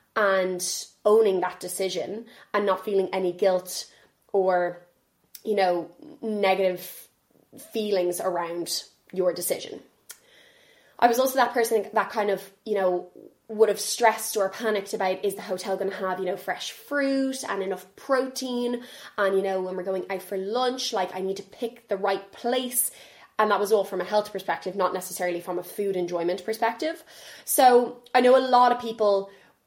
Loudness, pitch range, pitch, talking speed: -25 LUFS, 185-240 Hz, 200 Hz, 170 wpm